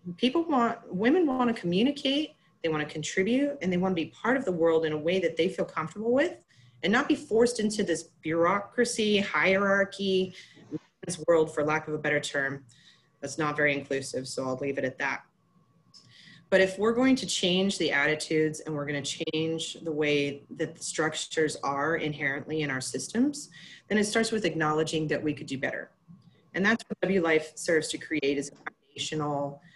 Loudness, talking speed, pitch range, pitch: -28 LUFS, 195 wpm, 150-200 Hz, 165 Hz